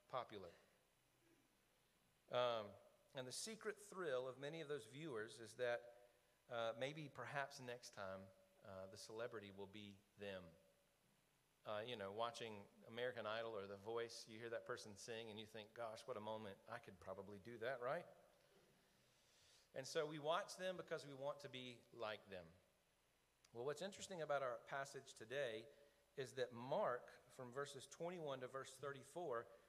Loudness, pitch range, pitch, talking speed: -51 LUFS, 105-140 Hz, 120 Hz, 160 wpm